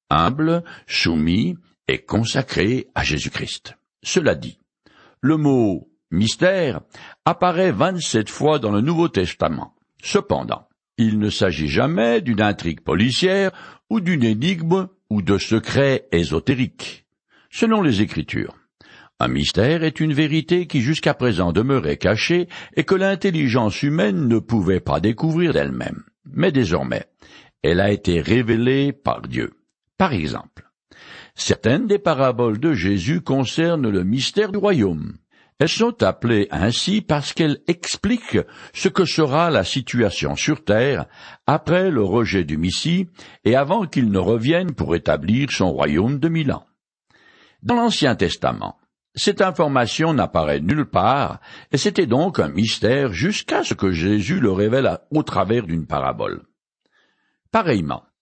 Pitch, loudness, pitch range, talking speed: 130 Hz, -20 LUFS, 105-170 Hz, 135 wpm